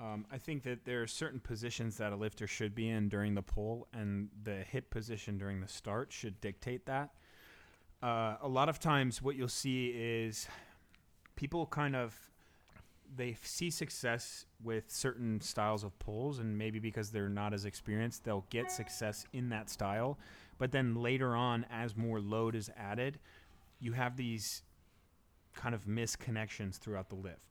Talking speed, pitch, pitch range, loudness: 170 wpm, 115 Hz, 105-125 Hz, -39 LUFS